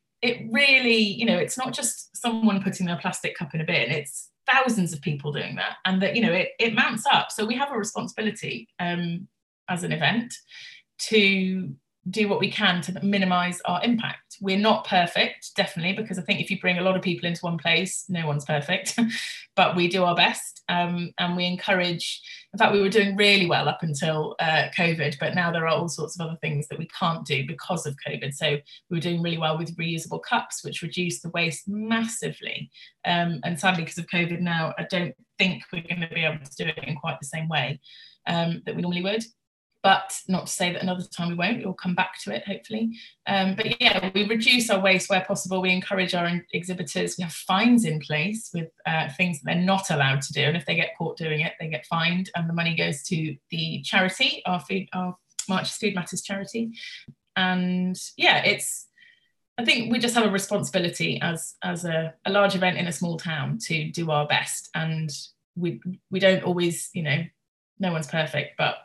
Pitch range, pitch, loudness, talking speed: 165-200 Hz, 180 Hz, -24 LUFS, 215 wpm